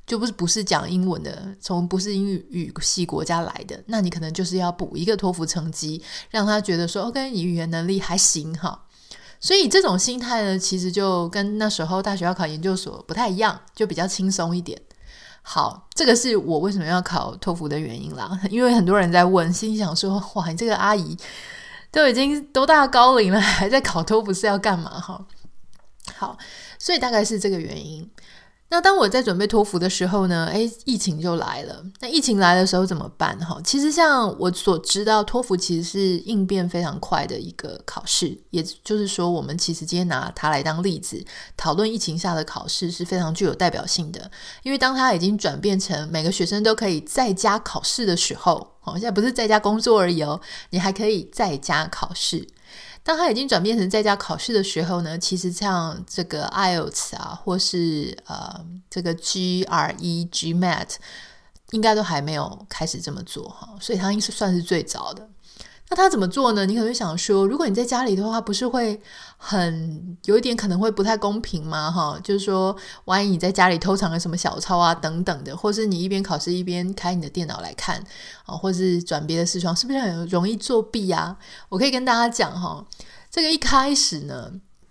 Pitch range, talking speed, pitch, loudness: 175-215 Hz, 305 characters per minute, 190 Hz, -21 LUFS